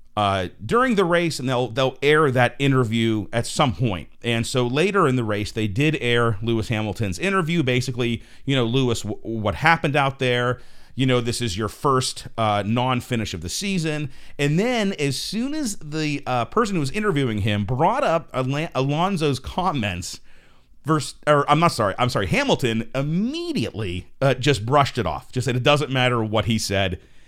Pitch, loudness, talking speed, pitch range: 125 Hz, -22 LUFS, 185 wpm, 115-150 Hz